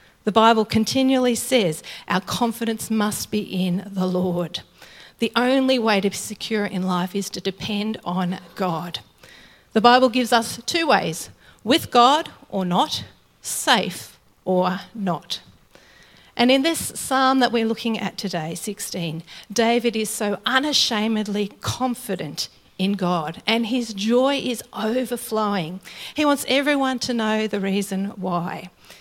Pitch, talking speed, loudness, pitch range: 215 Hz, 140 wpm, -22 LUFS, 190-240 Hz